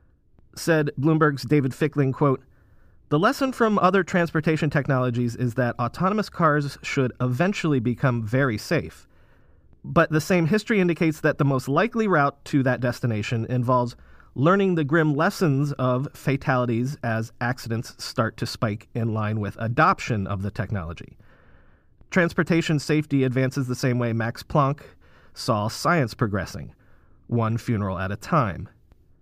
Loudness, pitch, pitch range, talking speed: -23 LUFS, 135 Hz, 120-160 Hz, 140 wpm